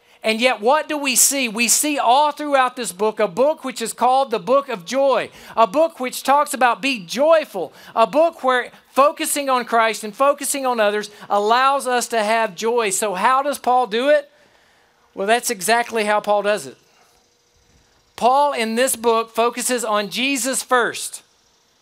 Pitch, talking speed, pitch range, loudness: 245 Hz, 175 wpm, 225-275 Hz, -18 LUFS